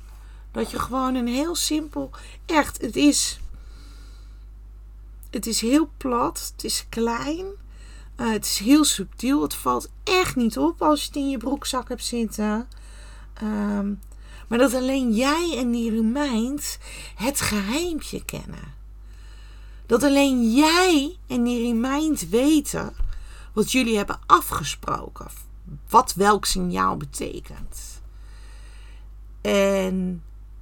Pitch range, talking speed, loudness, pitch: 185-280 Hz, 120 wpm, -22 LUFS, 235 Hz